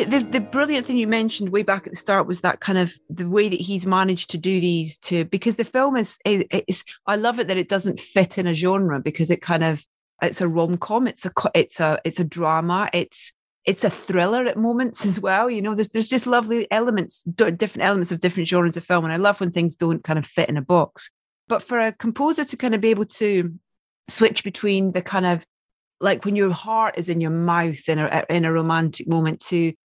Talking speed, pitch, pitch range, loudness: 235 wpm, 185 Hz, 170-220 Hz, -21 LUFS